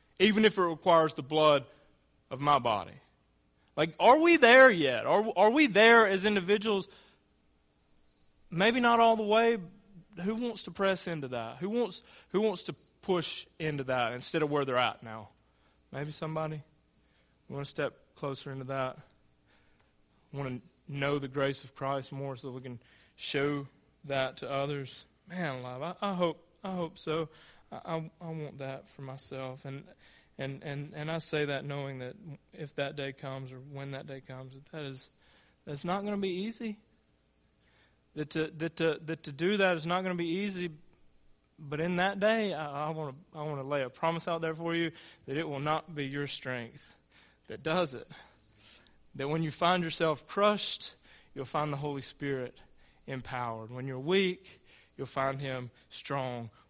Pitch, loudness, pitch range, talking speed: 150 Hz, -30 LUFS, 135-175 Hz, 180 wpm